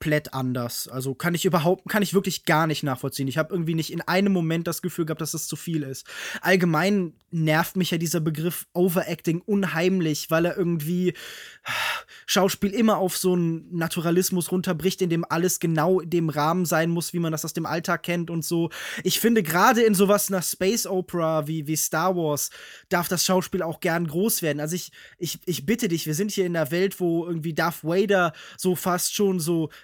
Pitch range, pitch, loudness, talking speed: 160-185 Hz, 175 Hz, -24 LUFS, 205 wpm